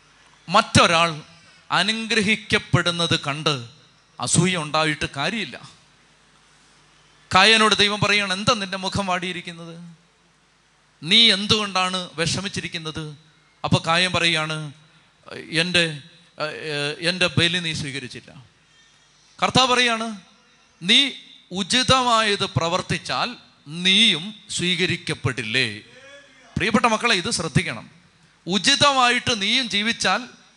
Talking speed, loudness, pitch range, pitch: 75 wpm, -19 LUFS, 155-210 Hz, 175 Hz